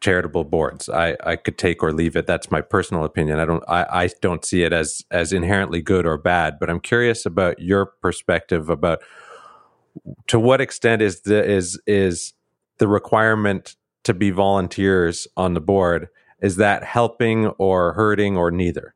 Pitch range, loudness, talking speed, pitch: 85-105 Hz, -20 LUFS, 175 wpm, 95 Hz